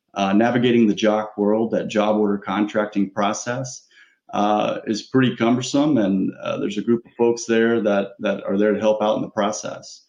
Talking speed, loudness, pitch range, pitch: 190 wpm, -20 LUFS, 105-120 Hz, 105 Hz